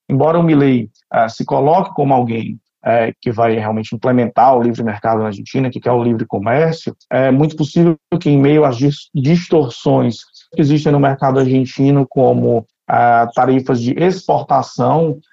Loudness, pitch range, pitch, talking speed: -14 LUFS, 120-150 Hz, 130 Hz, 150 wpm